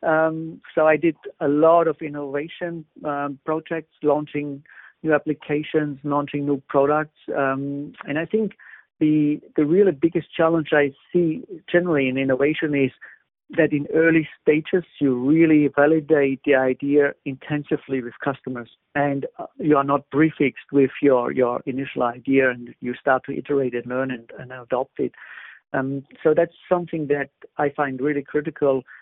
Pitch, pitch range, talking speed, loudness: 145 Hz, 135-160 Hz, 150 wpm, -22 LUFS